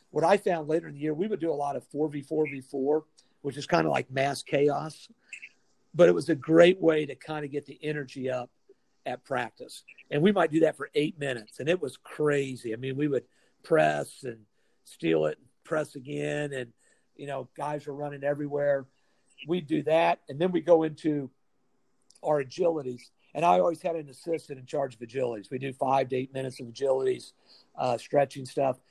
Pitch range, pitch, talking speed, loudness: 135-160 Hz, 145 Hz, 200 wpm, -28 LUFS